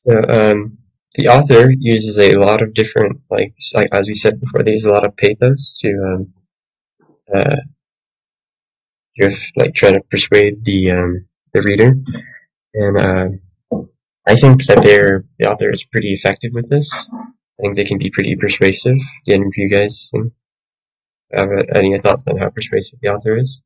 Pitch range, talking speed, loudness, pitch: 100-120 Hz, 170 wpm, -13 LUFS, 105 Hz